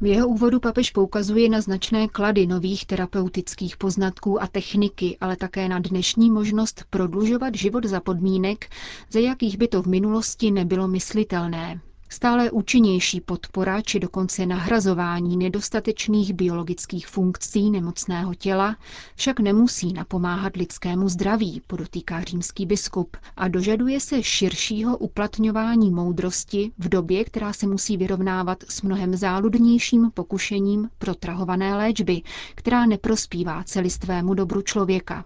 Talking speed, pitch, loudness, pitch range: 125 wpm, 195 Hz, -23 LUFS, 185-215 Hz